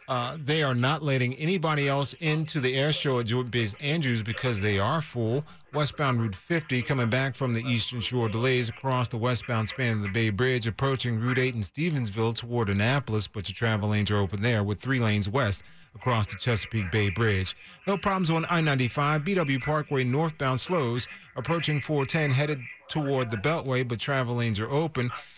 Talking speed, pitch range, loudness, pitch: 190 wpm, 115-145 Hz, -27 LUFS, 125 Hz